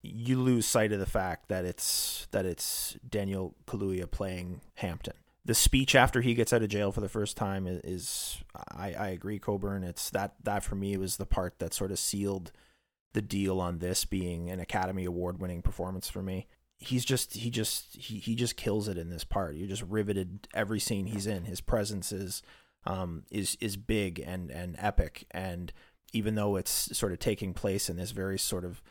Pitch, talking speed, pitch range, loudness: 100 Hz, 195 wpm, 90-105 Hz, -32 LUFS